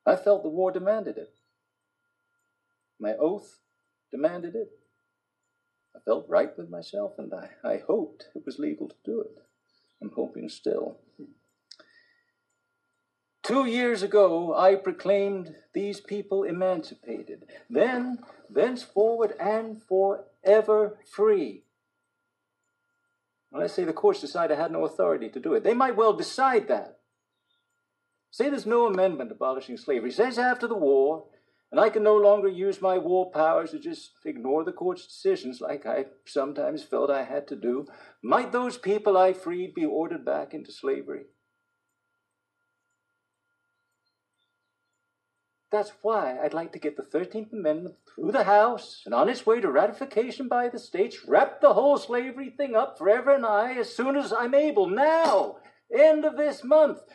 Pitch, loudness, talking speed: 205 Hz, -25 LUFS, 150 wpm